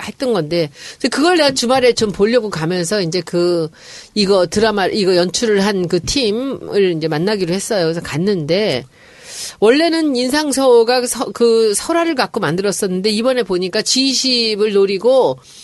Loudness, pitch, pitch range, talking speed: -15 LUFS, 215 Hz, 185-255 Hz, 310 characters per minute